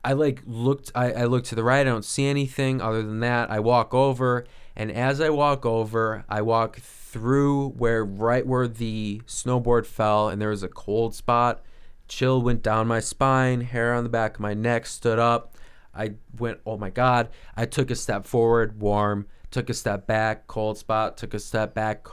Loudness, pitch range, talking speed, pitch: -24 LUFS, 110-125 Hz, 200 wpm, 115 Hz